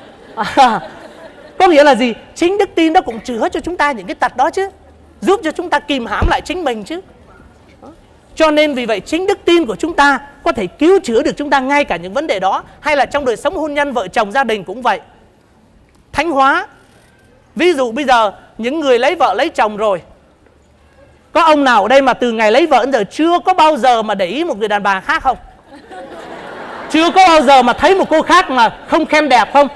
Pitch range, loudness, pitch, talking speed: 250-330 Hz, -13 LUFS, 290 Hz, 235 wpm